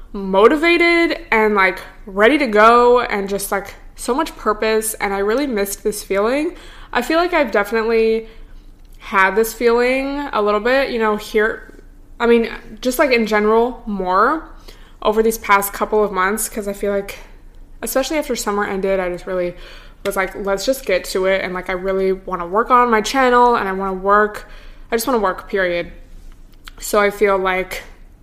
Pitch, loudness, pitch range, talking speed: 215 Hz, -17 LUFS, 195-240 Hz, 185 wpm